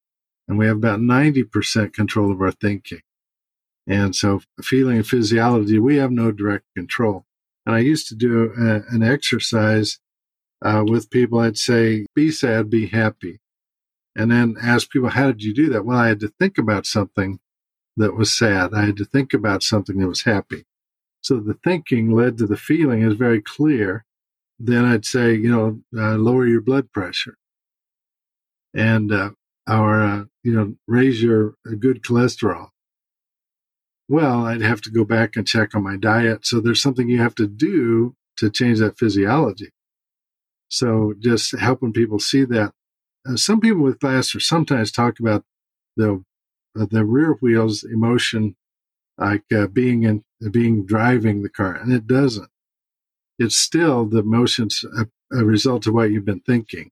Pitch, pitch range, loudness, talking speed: 115 Hz, 105-125 Hz, -19 LUFS, 170 wpm